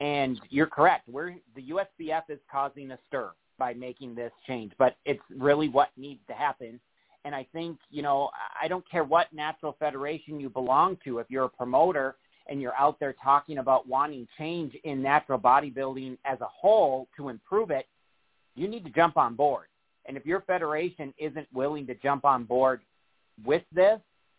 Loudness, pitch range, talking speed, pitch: -28 LUFS, 130-155 Hz, 180 wpm, 140 Hz